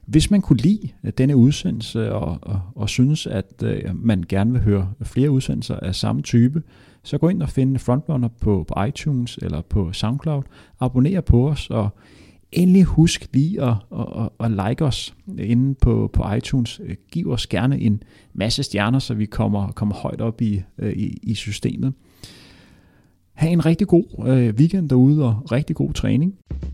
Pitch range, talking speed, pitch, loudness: 105-140 Hz, 165 wpm, 120 Hz, -20 LUFS